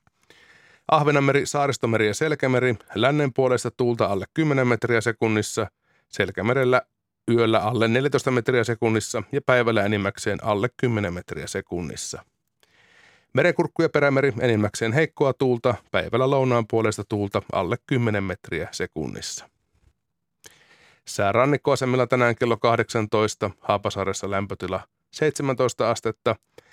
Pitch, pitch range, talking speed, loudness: 120 Hz, 110-135 Hz, 105 wpm, -23 LUFS